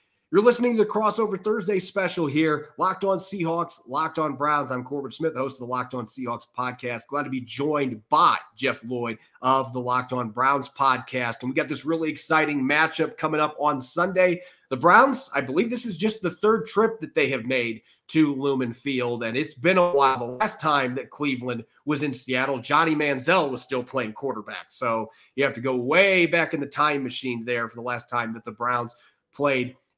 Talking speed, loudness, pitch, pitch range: 210 wpm, -24 LUFS, 140 Hz, 125-165 Hz